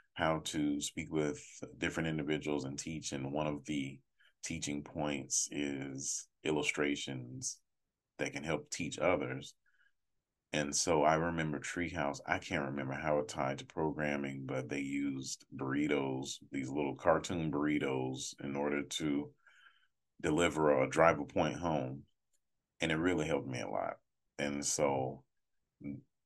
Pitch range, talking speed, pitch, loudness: 70-75 Hz, 135 wpm, 75 Hz, -36 LUFS